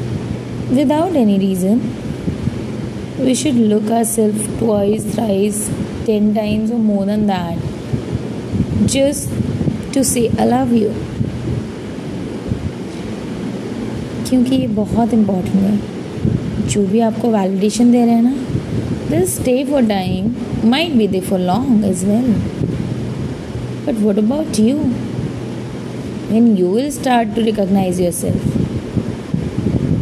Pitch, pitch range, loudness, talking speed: 220 Hz, 200-240 Hz, -17 LUFS, 115 wpm